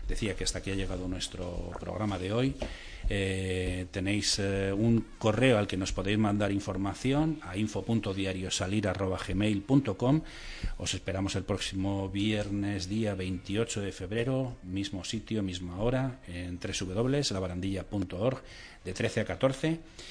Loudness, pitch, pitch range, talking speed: -31 LUFS, 100 Hz, 95-110 Hz, 125 wpm